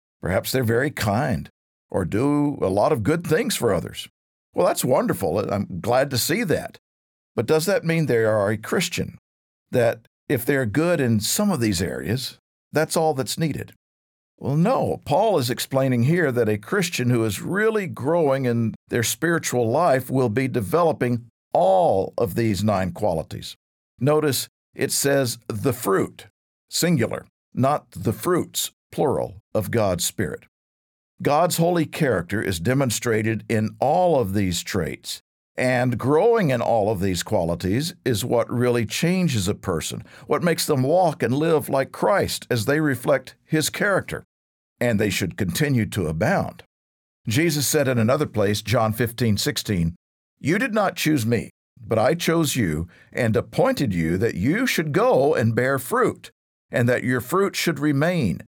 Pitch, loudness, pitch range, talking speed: 125 Hz, -22 LUFS, 105-150 Hz, 160 wpm